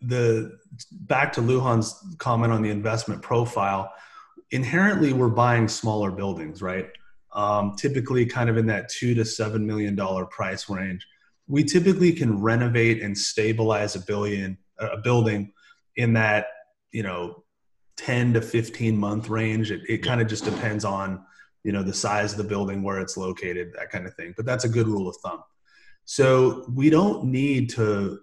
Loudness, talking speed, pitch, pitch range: -24 LUFS, 170 wpm, 110 Hz, 100-120 Hz